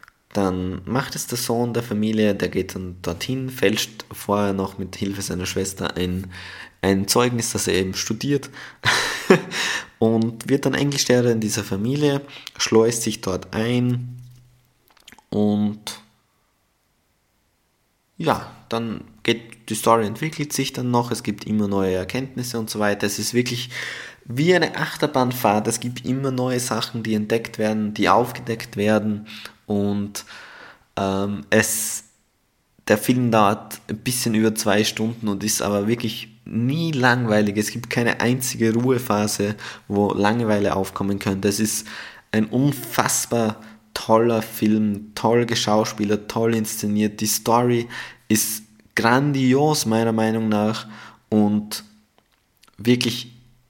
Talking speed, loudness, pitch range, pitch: 130 wpm, -21 LUFS, 105-120 Hz, 110 Hz